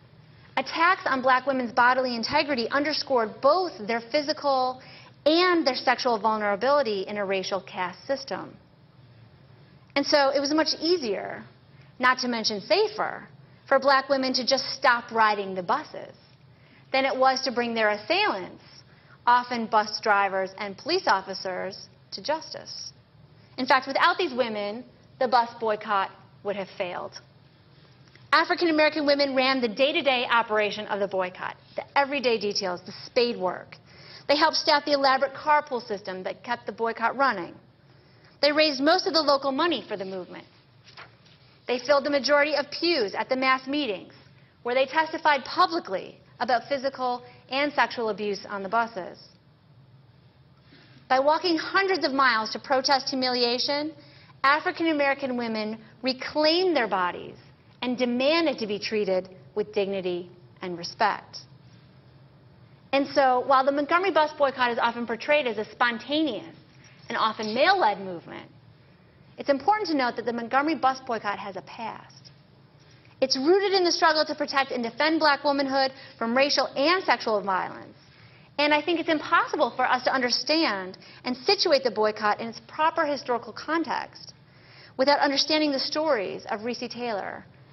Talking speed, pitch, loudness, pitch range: 150 wpm, 255 Hz, -25 LUFS, 205-285 Hz